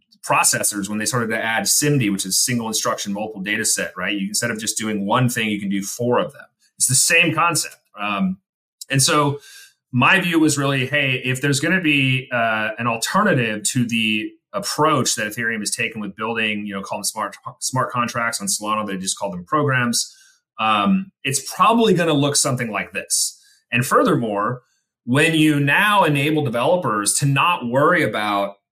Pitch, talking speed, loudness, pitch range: 120 Hz, 190 wpm, -19 LUFS, 105-150 Hz